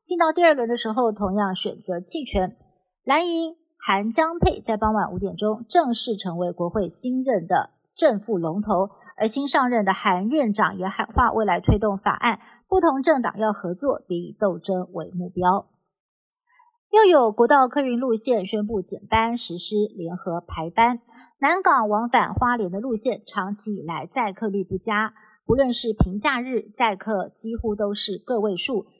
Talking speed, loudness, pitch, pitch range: 250 characters per minute, -22 LUFS, 215 Hz, 195-250 Hz